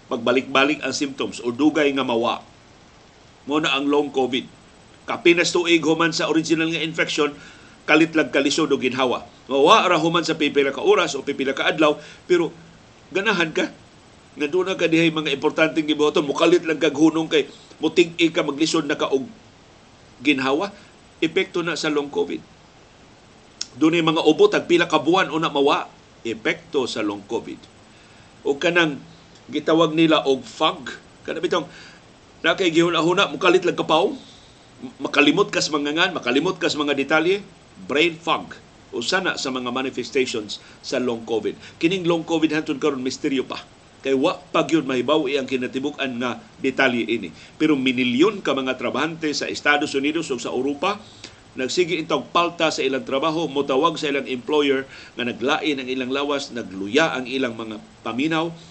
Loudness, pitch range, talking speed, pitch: -21 LUFS, 135-165 Hz, 160 wpm, 150 Hz